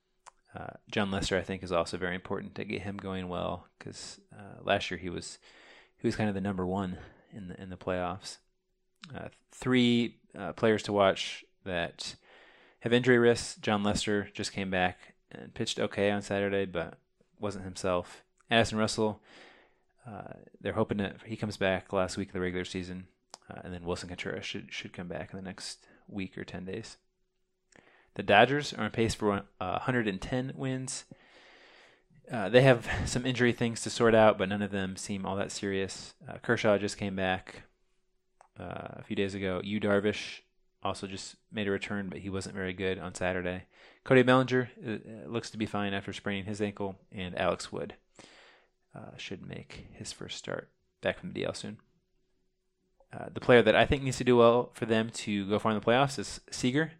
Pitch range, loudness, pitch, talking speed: 95-120 Hz, -30 LUFS, 105 Hz, 190 wpm